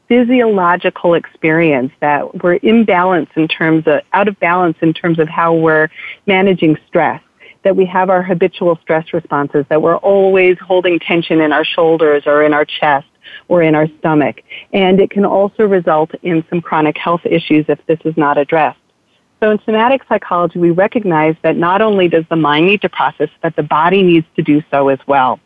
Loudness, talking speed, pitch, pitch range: -12 LUFS, 190 wpm, 170 Hz, 155-185 Hz